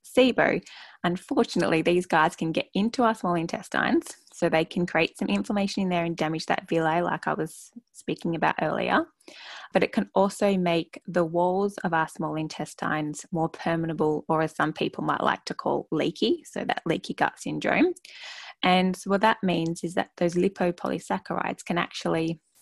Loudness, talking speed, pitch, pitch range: -26 LUFS, 175 wpm, 180 Hz, 165-215 Hz